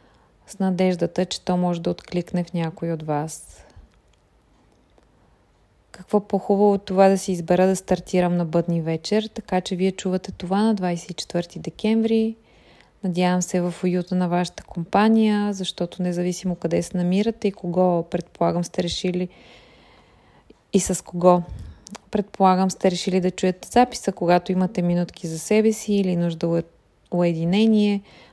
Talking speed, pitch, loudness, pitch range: 140 wpm, 180 Hz, -22 LUFS, 175-195 Hz